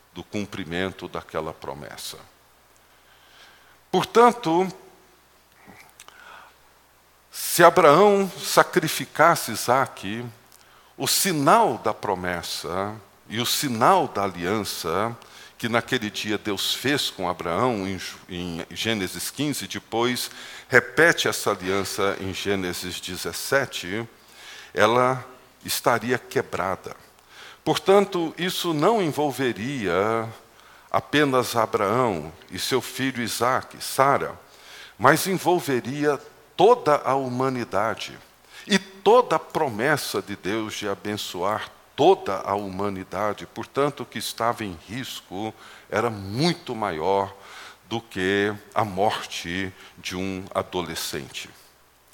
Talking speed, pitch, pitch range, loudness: 95 wpm, 115 Hz, 95-135 Hz, -23 LUFS